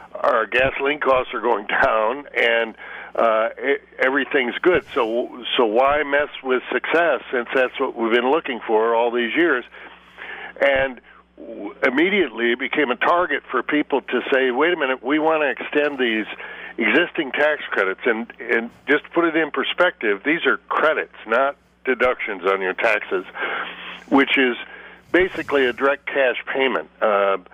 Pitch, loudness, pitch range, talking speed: 135 Hz, -20 LUFS, 120-150 Hz, 160 wpm